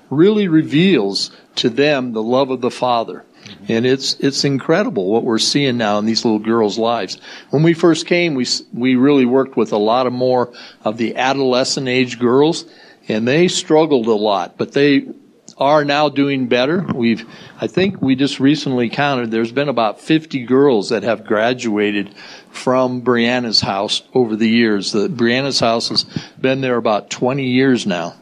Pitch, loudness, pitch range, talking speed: 130 Hz, -16 LUFS, 115-140 Hz, 175 wpm